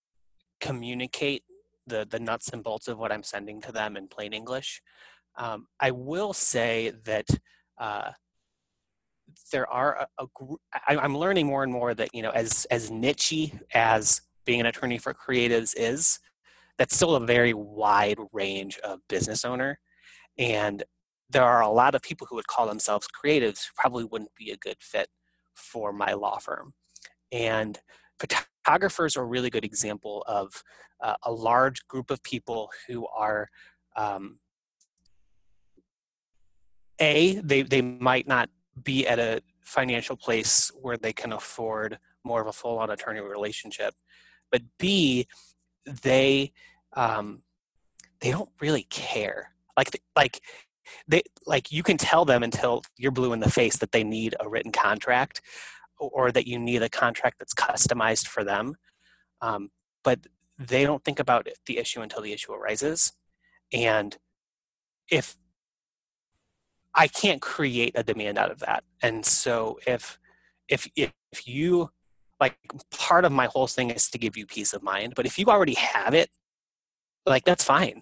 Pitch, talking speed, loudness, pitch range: 120 Hz, 155 wpm, -24 LUFS, 105-135 Hz